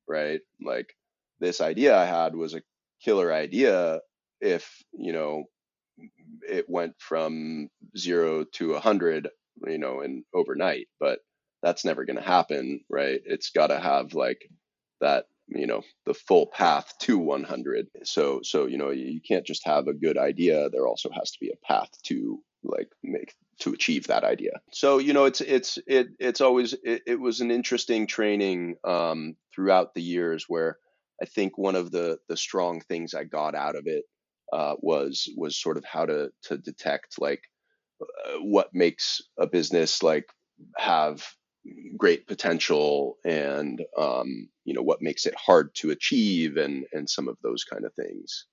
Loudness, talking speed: -26 LUFS, 170 wpm